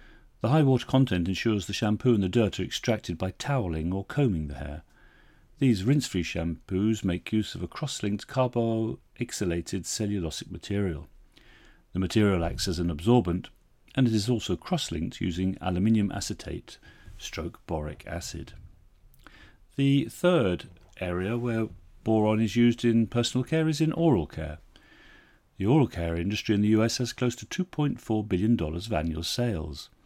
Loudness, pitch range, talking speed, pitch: -28 LUFS, 85-120 Hz, 155 wpm, 105 Hz